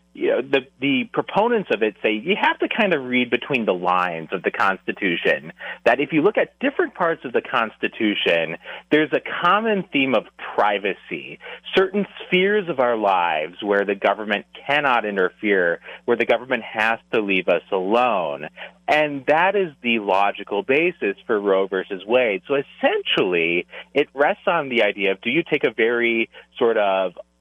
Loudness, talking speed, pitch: -21 LUFS, 175 wpm, 125 Hz